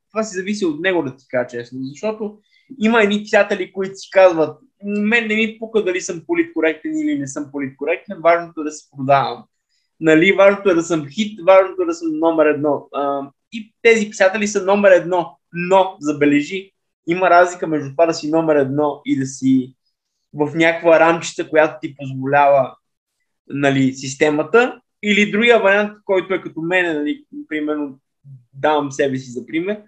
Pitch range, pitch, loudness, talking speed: 145-200 Hz, 170 Hz, -17 LUFS, 175 wpm